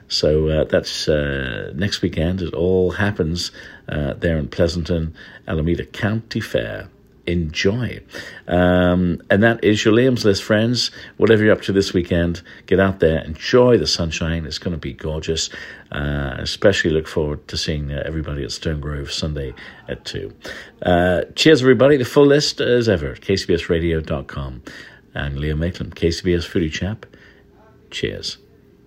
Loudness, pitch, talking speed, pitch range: -19 LUFS, 85 Hz, 150 wpm, 80-100 Hz